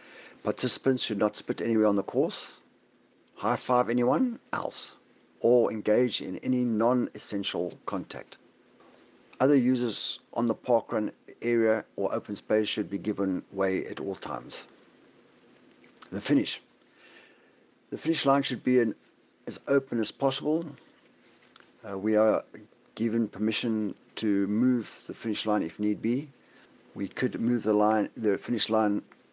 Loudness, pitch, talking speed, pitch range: -28 LUFS, 115 Hz, 140 wpm, 105-125 Hz